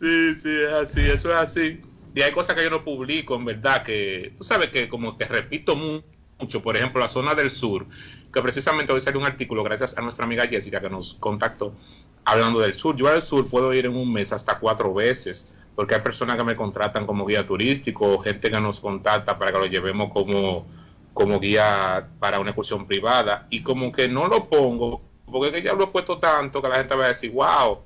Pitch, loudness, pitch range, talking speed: 120 Hz, -22 LUFS, 105-140 Hz, 220 wpm